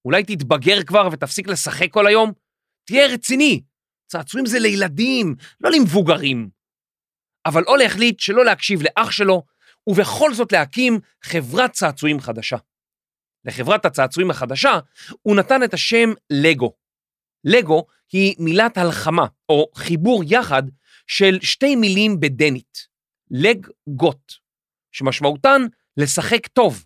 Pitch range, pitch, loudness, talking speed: 145-225 Hz, 185 Hz, -17 LUFS, 110 wpm